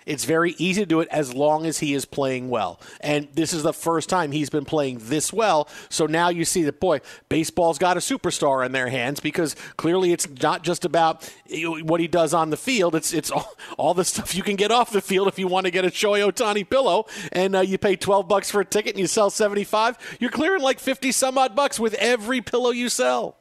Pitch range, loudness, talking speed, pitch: 155-205 Hz, -22 LUFS, 245 wpm, 175 Hz